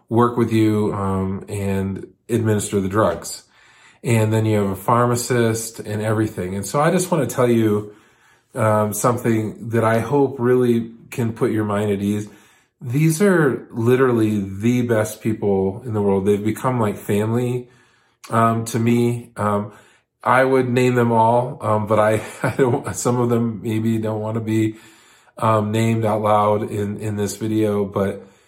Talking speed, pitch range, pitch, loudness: 170 wpm, 105-120 Hz, 110 Hz, -19 LUFS